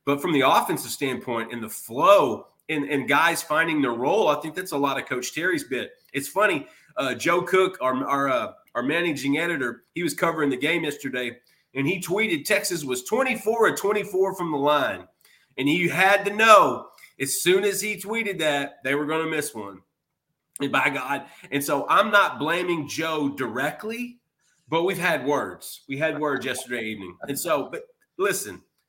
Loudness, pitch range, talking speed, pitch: -23 LUFS, 140-195 Hz, 190 wpm, 155 Hz